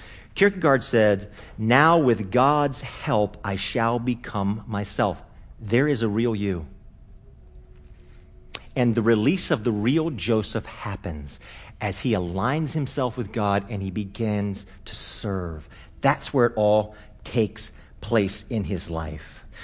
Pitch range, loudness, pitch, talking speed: 100-120 Hz, -24 LUFS, 105 Hz, 130 wpm